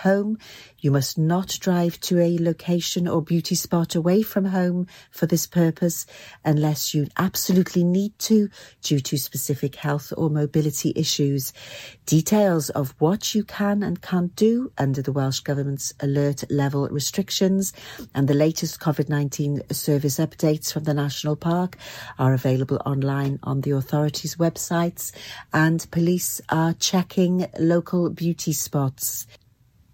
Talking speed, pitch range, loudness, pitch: 140 wpm, 140-175 Hz, -23 LUFS, 155 Hz